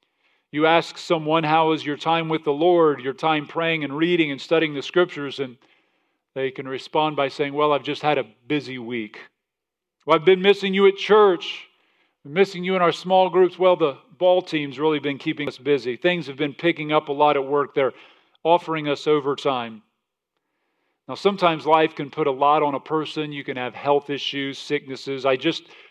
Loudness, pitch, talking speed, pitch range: -21 LUFS, 155 Hz, 200 wpm, 140-170 Hz